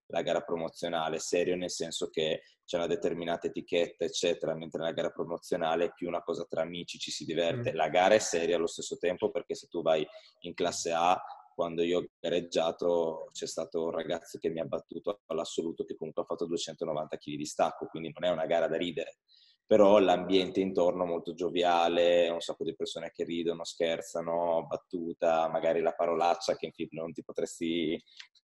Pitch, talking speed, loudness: 85 Hz, 190 wpm, -31 LUFS